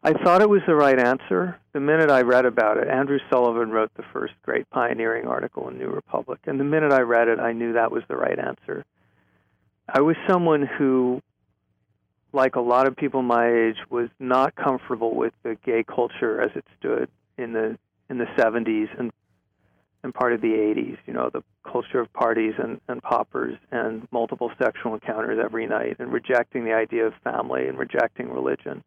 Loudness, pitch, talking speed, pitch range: -23 LUFS, 120 Hz, 195 wpm, 110-130 Hz